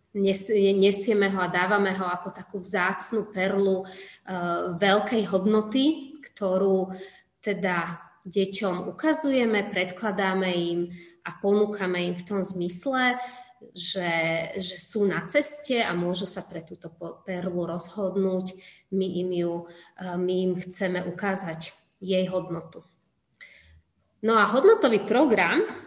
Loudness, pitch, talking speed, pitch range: -26 LUFS, 190 Hz, 110 wpm, 180-200 Hz